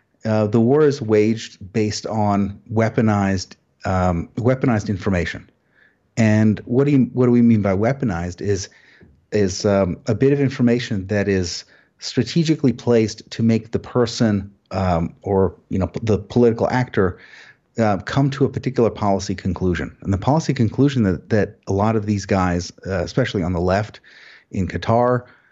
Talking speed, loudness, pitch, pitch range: 160 wpm, -20 LUFS, 110 Hz, 95-120 Hz